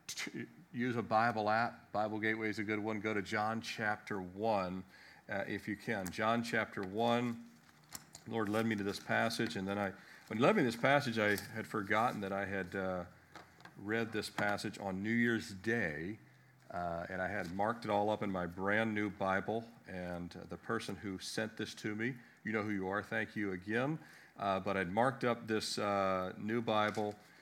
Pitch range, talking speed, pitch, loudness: 95-115 Hz, 200 wpm, 105 Hz, -37 LUFS